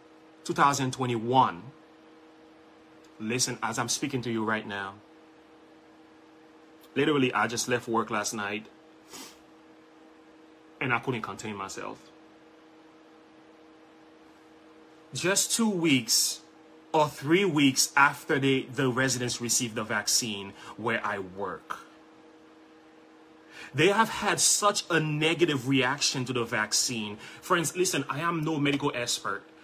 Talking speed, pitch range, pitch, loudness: 110 wpm, 125-160 Hz, 155 Hz, -27 LUFS